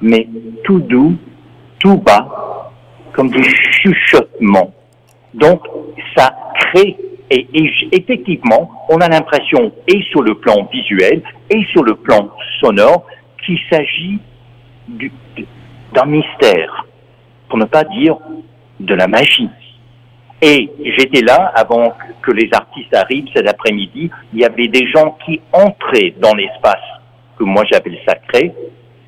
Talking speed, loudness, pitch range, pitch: 130 wpm, -11 LUFS, 120-170 Hz, 150 Hz